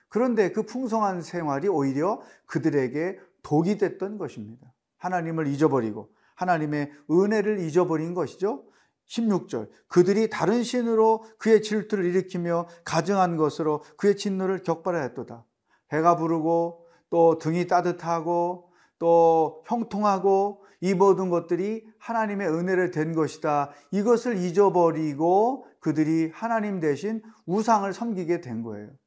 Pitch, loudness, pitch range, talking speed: 175 Hz, -25 LUFS, 160-205 Hz, 295 characters per minute